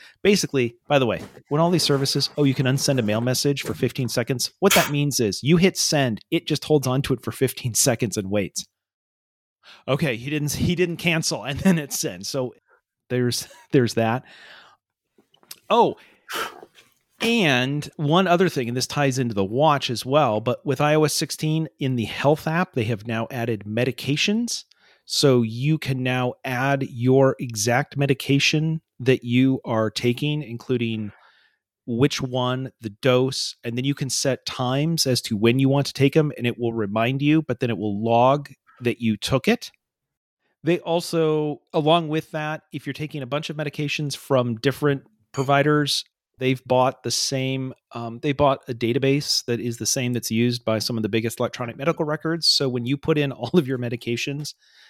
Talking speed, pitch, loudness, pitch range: 185 wpm, 135 Hz, -22 LUFS, 120-150 Hz